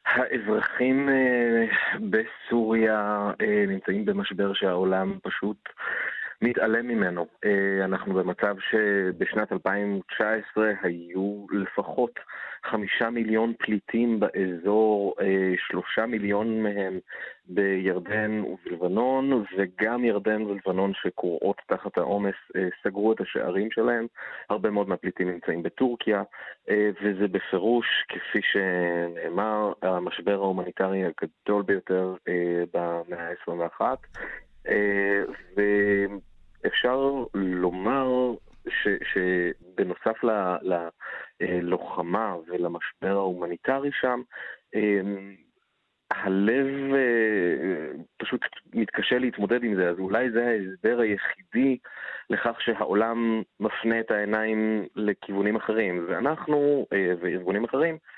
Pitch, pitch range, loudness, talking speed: 100 Hz, 95-115 Hz, -26 LUFS, 80 wpm